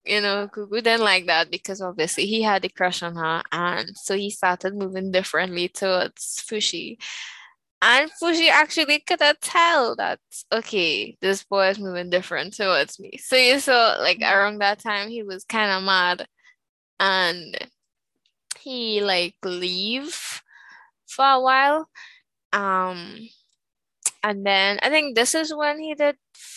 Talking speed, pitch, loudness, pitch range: 150 wpm, 205 Hz, -21 LUFS, 185-265 Hz